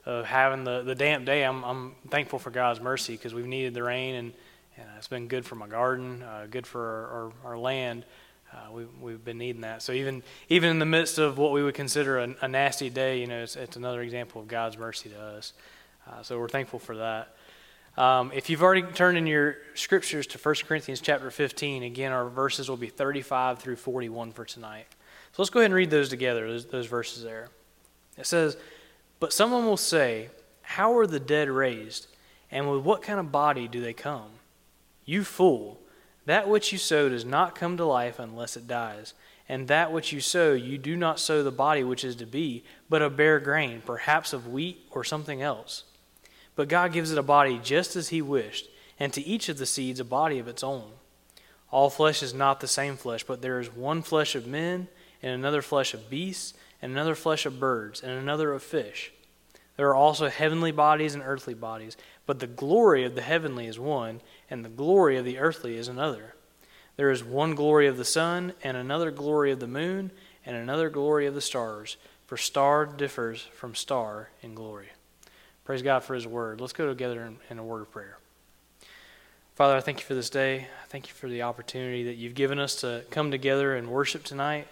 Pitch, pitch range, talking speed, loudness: 135 Hz, 120-150 Hz, 215 wpm, -27 LUFS